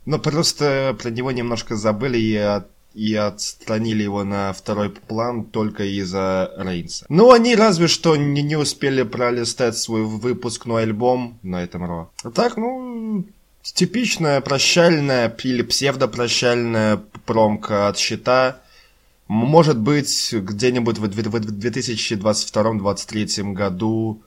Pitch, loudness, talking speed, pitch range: 115 Hz, -19 LUFS, 115 wpm, 105-140 Hz